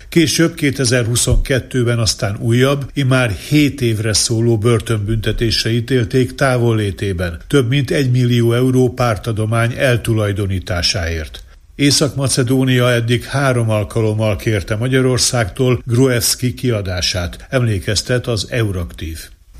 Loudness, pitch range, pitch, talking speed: -15 LUFS, 105-130 Hz, 120 Hz, 90 wpm